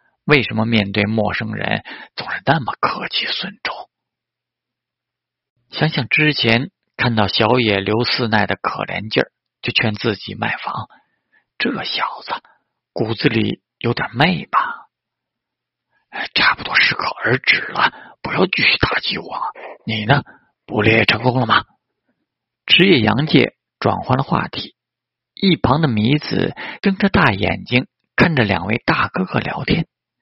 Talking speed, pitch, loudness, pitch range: 200 characters per minute, 115 Hz, -17 LUFS, 110-145 Hz